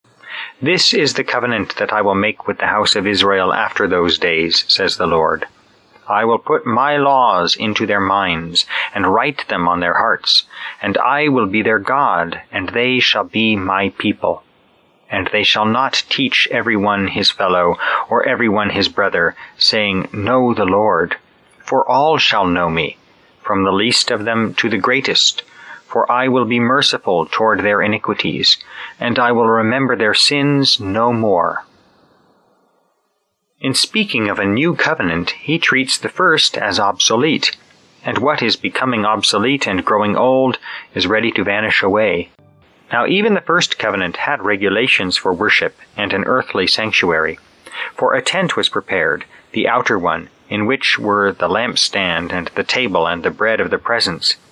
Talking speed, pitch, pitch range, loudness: 165 wpm, 110 Hz, 100-125 Hz, -15 LUFS